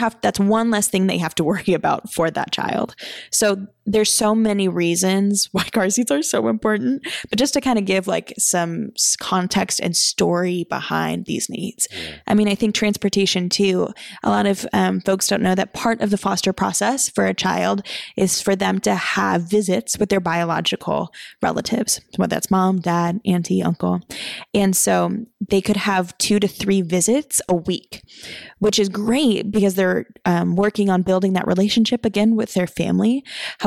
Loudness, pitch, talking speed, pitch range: -19 LUFS, 195 Hz, 185 wpm, 180-215 Hz